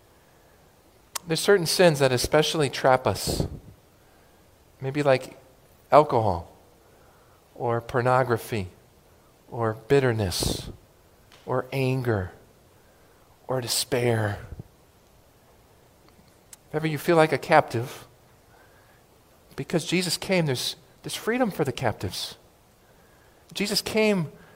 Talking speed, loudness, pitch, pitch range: 90 wpm, -24 LUFS, 130 Hz, 110-155 Hz